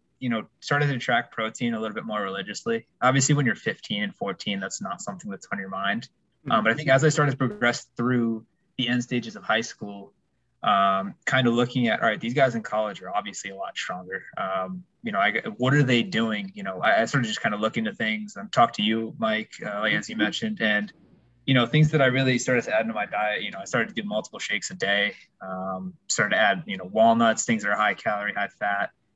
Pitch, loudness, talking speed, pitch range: 125 Hz, -25 LUFS, 250 wpm, 110-155 Hz